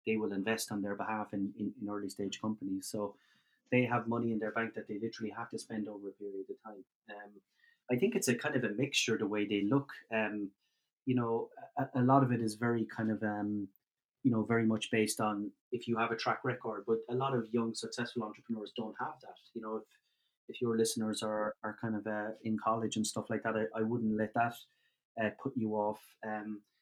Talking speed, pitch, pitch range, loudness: 235 wpm, 110 Hz, 105-115 Hz, -35 LUFS